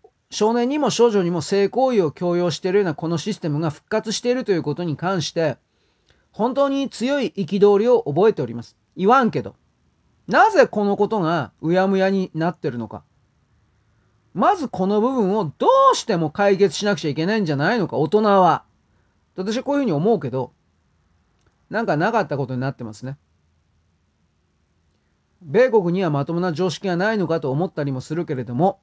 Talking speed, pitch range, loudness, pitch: 355 characters per minute, 125-210 Hz, -20 LUFS, 175 Hz